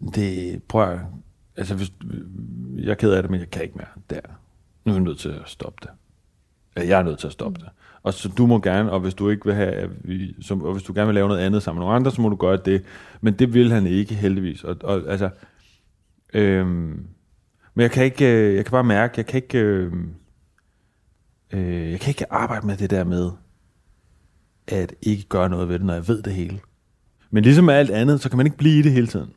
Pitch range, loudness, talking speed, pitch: 90-110 Hz, -21 LUFS, 230 wpm, 100 Hz